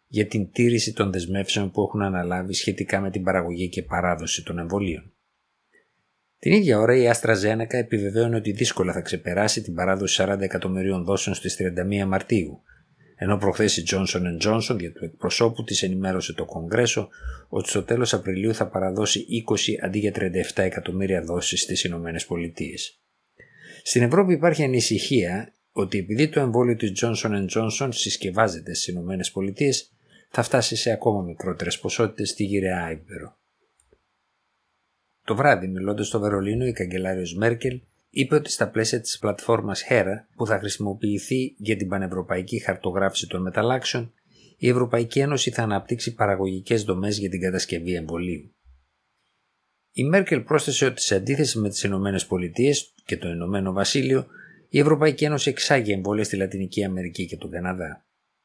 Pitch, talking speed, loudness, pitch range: 100 Hz, 150 wpm, -24 LUFS, 95-115 Hz